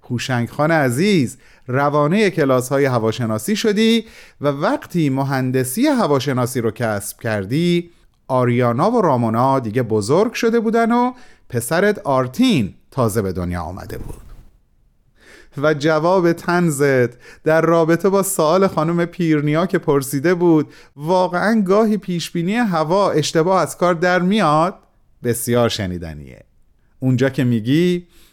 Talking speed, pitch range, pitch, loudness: 120 wpm, 125-180 Hz, 155 Hz, -17 LUFS